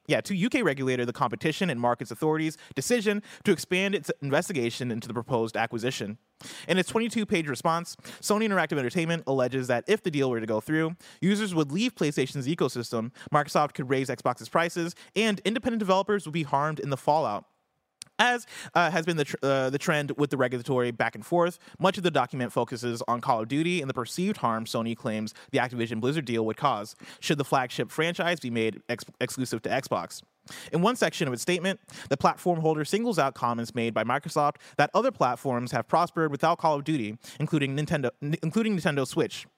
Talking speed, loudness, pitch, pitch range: 195 wpm, -28 LUFS, 150 Hz, 125-175 Hz